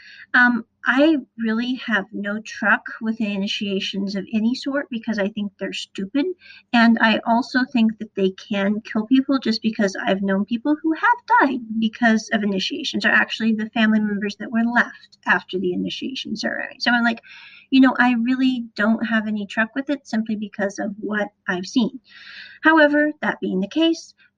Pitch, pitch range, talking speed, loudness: 225 Hz, 210-265 Hz, 175 wpm, -21 LUFS